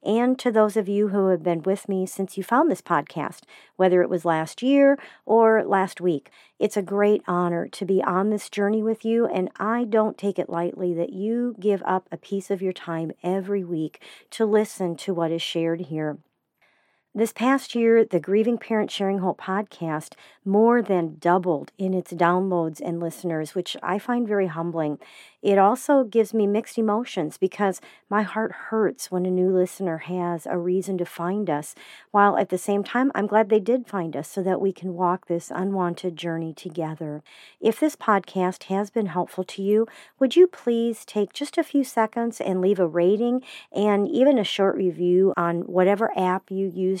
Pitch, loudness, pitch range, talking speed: 195 Hz, -23 LUFS, 175-220 Hz, 190 wpm